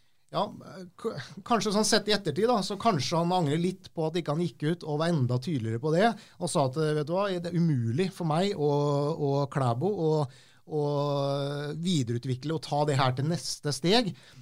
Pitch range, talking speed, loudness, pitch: 145-180 Hz, 205 wpm, -28 LUFS, 155 Hz